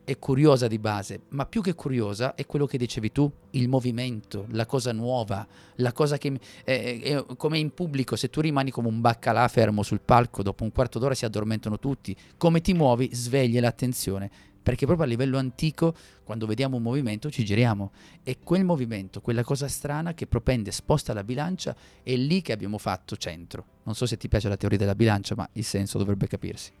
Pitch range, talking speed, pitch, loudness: 105-140 Hz, 200 wpm, 120 Hz, -26 LUFS